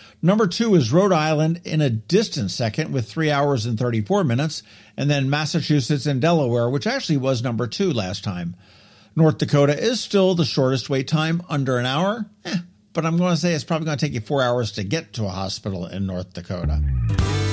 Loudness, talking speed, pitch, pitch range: -21 LUFS, 205 wpm, 145 Hz, 115-165 Hz